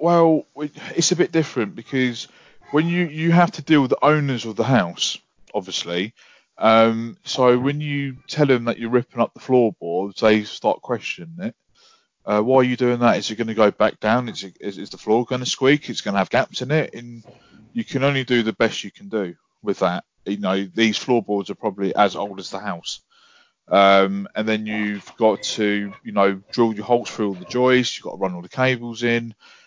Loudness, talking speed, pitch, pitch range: -20 LUFS, 220 wpm, 120 Hz, 105-140 Hz